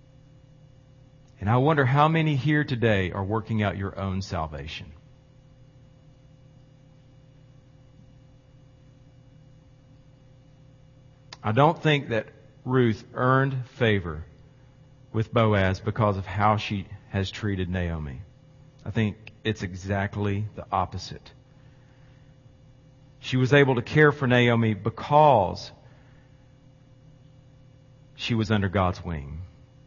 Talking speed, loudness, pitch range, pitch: 95 wpm, -24 LUFS, 105-135 Hz, 130 Hz